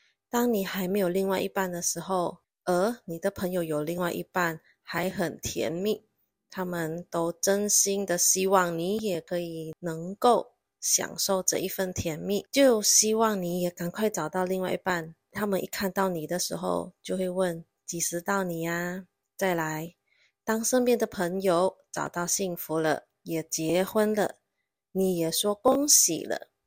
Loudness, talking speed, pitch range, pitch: -27 LUFS, 225 characters per minute, 170-200 Hz, 185 Hz